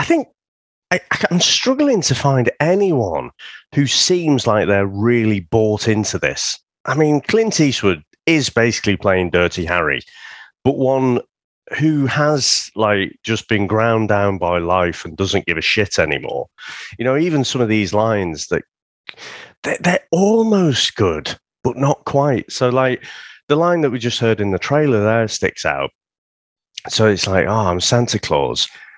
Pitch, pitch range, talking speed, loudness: 120 Hz, 100-145 Hz, 160 wpm, -17 LUFS